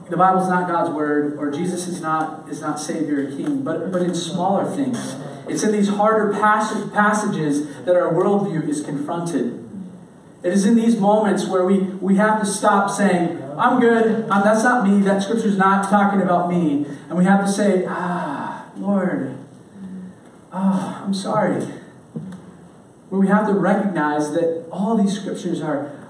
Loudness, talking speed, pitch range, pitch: -19 LUFS, 170 wpm, 170-205 Hz, 190 Hz